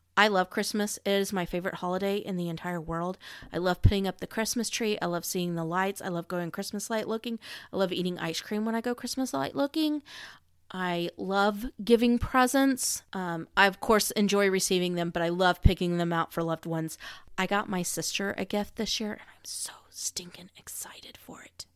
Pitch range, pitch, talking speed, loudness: 175-215 Hz, 190 Hz, 210 wpm, -29 LUFS